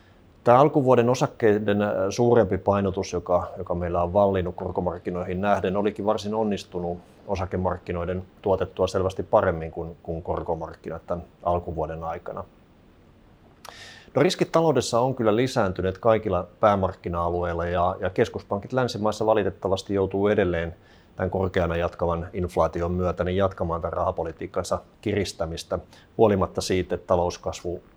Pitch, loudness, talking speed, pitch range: 95 Hz, -25 LUFS, 115 wpm, 90-105 Hz